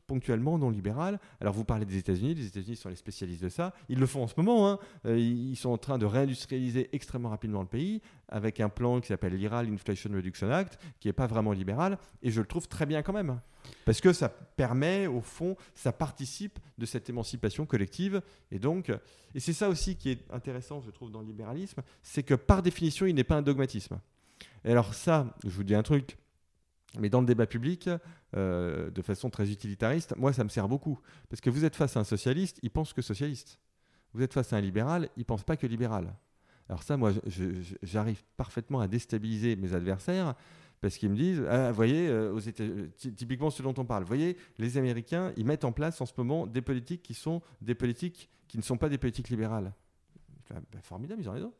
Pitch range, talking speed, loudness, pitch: 110-150 Hz, 220 wpm, -32 LUFS, 125 Hz